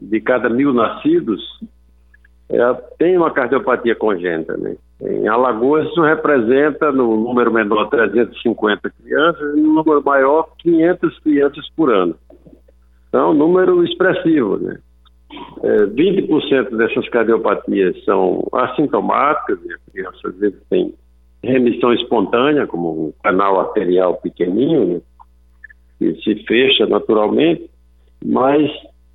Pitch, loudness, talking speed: 145 Hz, -16 LUFS, 110 wpm